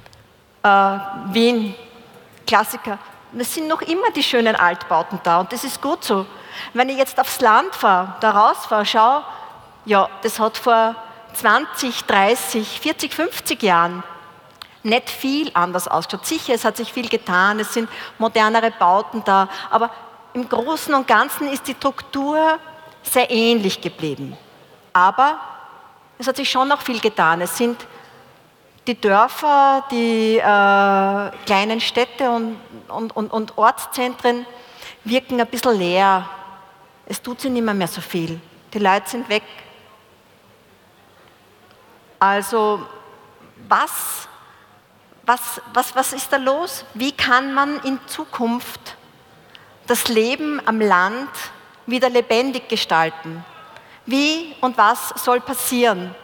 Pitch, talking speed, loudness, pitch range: 230 Hz, 130 wpm, -18 LUFS, 195-255 Hz